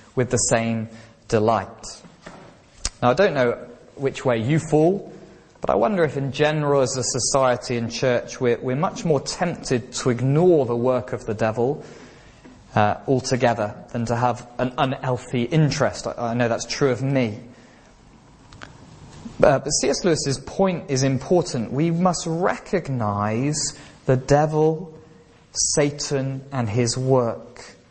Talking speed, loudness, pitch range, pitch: 140 wpm, -22 LUFS, 120-150 Hz, 130 Hz